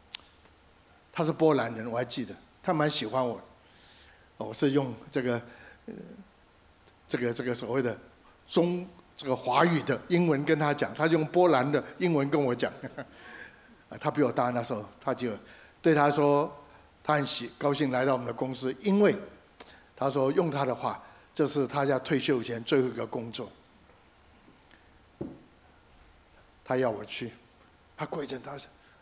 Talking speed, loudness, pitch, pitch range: 205 characters per minute, -29 LUFS, 135 Hz, 120-150 Hz